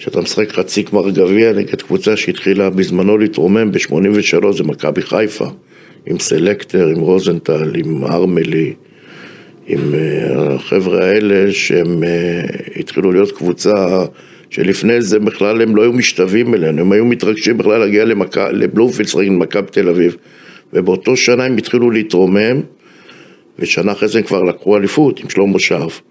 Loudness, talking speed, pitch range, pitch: -13 LUFS, 140 wpm, 95-110 Hz, 100 Hz